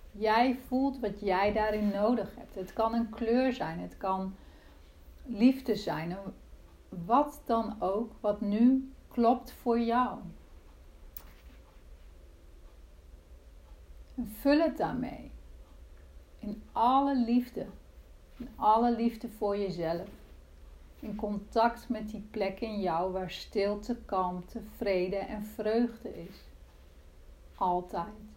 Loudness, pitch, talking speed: -31 LUFS, 205 Hz, 110 wpm